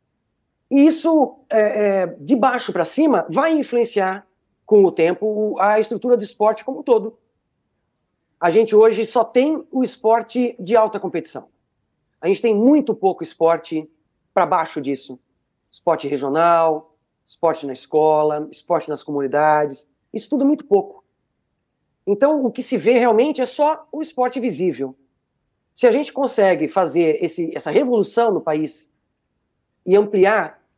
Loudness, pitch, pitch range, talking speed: -18 LUFS, 210 Hz, 160-245 Hz, 140 wpm